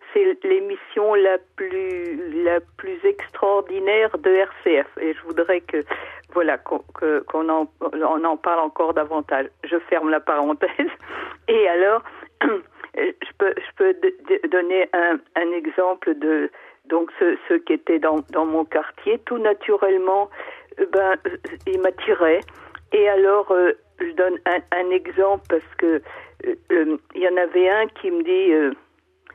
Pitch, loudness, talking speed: 195 Hz, -21 LUFS, 135 wpm